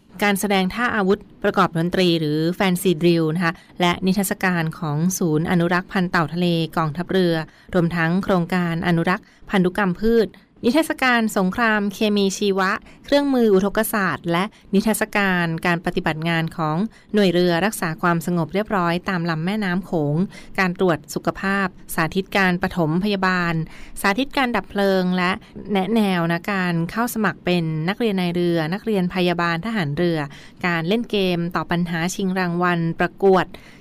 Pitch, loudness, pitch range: 185 Hz, -21 LUFS, 170-200 Hz